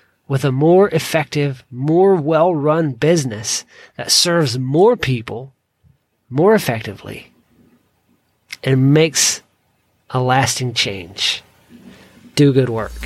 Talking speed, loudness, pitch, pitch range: 100 wpm, -16 LUFS, 140 Hz, 125-160 Hz